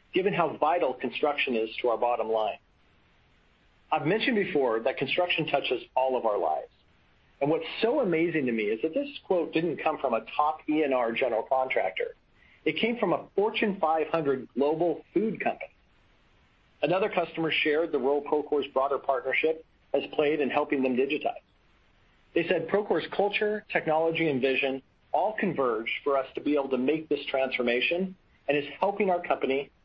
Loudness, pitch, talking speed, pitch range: -28 LUFS, 145 Hz, 165 wpm, 135-165 Hz